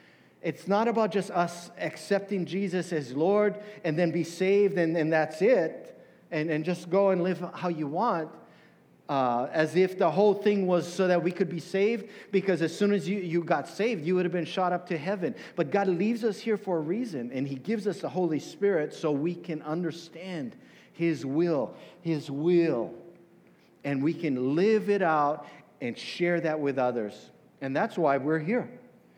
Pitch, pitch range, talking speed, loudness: 175 Hz, 160-200 Hz, 195 wpm, -28 LUFS